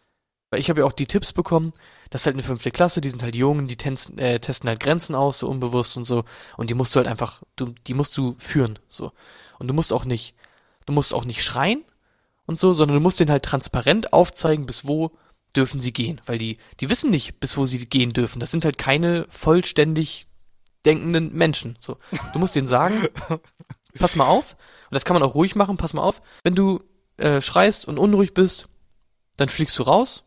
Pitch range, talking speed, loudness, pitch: 125-165 Hz, 220 wpm, -20 LUFS, 140 Hz